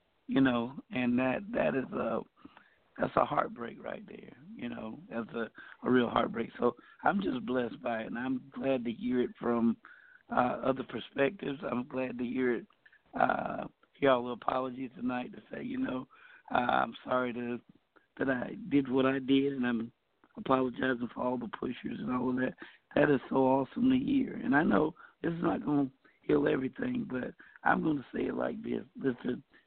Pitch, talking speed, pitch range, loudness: 130 Hz, 190 wpm, 125-140 Hz, -32 LUFS